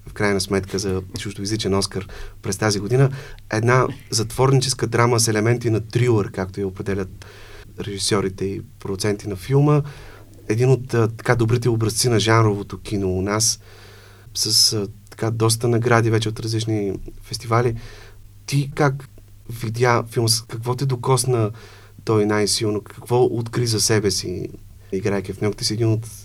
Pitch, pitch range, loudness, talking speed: 110 Hz, 100-120 Hz, -20 LUFS, 140 wpm